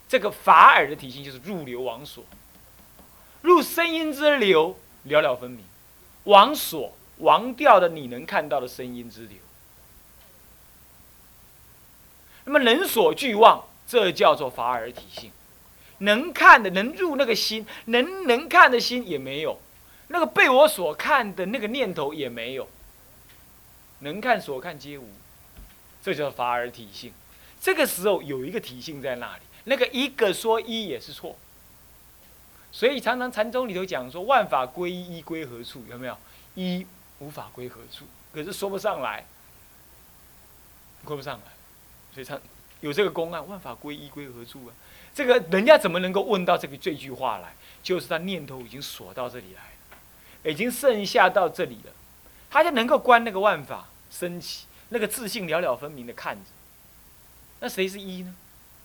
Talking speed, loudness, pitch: 230 characters per minute, -22 LUFS, 180 Hz